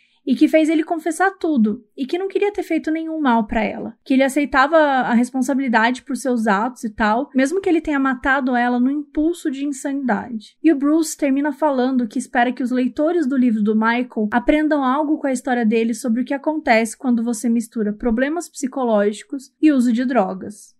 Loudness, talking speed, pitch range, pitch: -19 LUFS, 200 wpm, 235-305 Hz, 265 Hz